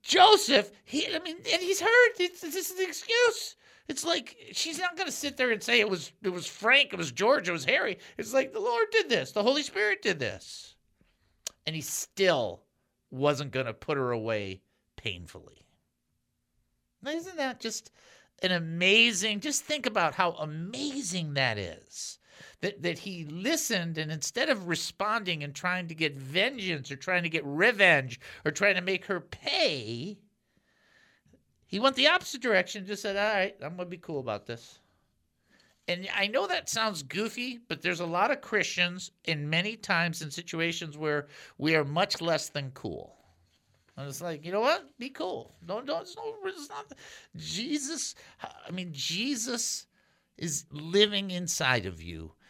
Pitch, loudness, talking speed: 185 Hz, -28 LUFS, 175 wpm